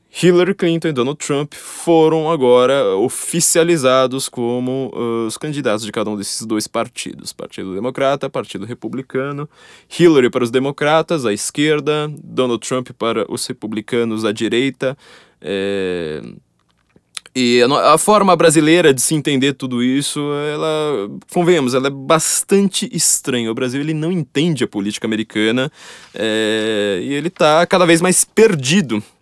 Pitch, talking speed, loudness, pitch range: 140 Hz, 140 wpm, -16 LUFS, 120-165 Hz